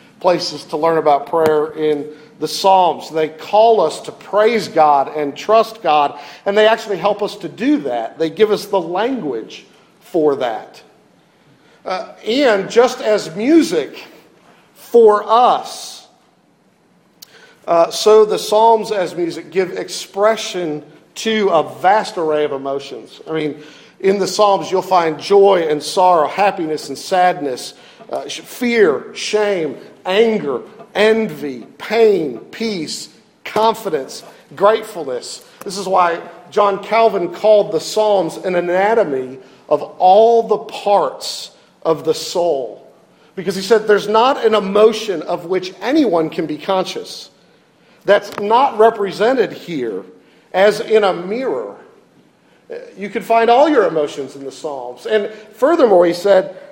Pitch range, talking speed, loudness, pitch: 160-220 Hz, 135 wpm, -15 LUFS, 200 Hz